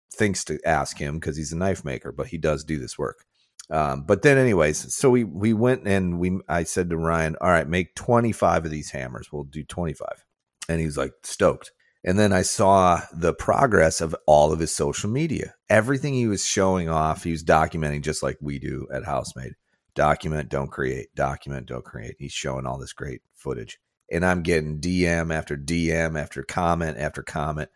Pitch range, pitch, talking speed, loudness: 75-90 Hz, 80 Hz, 200 wpm, -23 LUFS